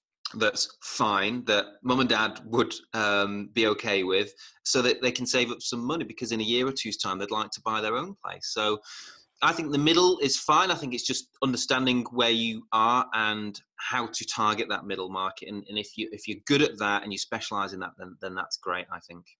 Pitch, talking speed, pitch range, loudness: 110 Hz, 230 wpm, 105-125 Hz, -27 LUFS